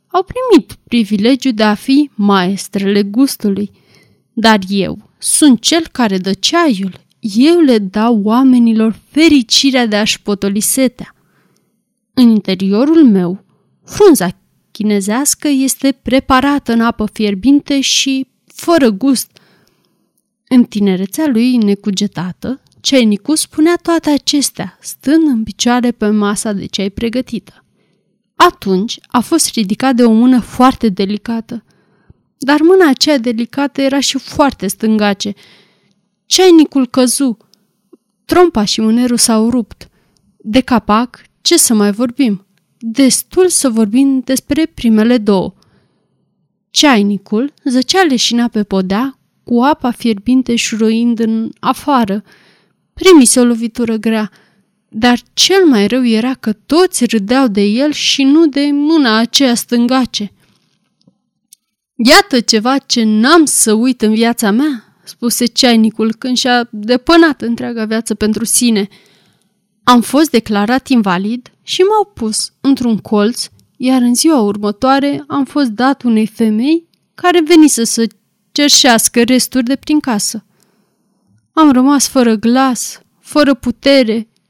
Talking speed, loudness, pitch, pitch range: 120 wpm, -11 LUFS, 235 Hz, 215-270 Hz